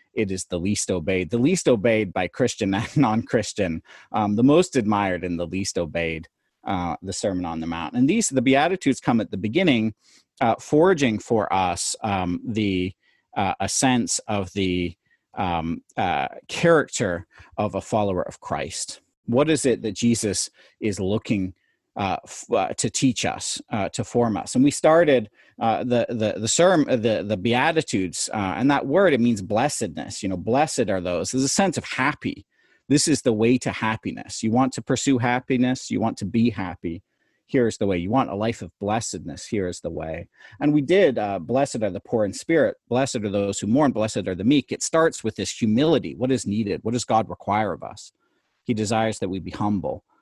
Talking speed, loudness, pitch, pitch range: 200 wpm, -23 LUFS, 110 Hz, 95-125 Hz